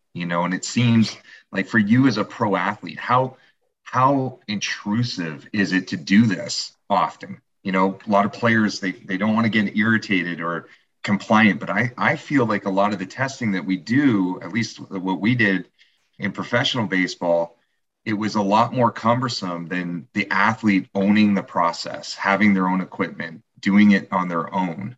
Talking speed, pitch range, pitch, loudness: 185 wpm, 95-110 Hz, 100 Hz, -21 LUFS